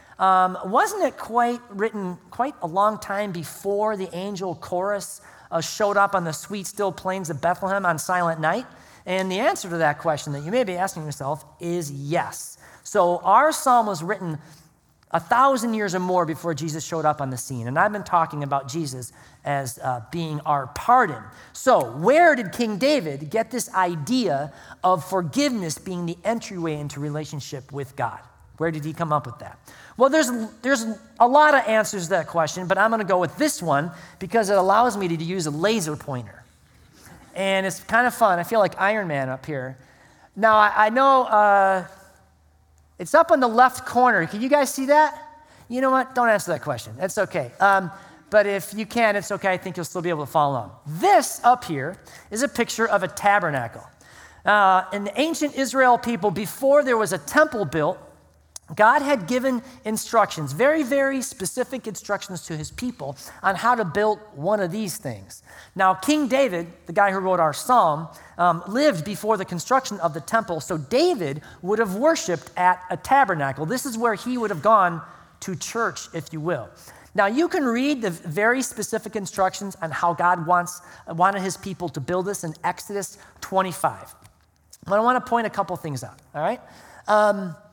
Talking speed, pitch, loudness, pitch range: 195 wpm, 190 Hz, -22 LUFS, 165-225 Hz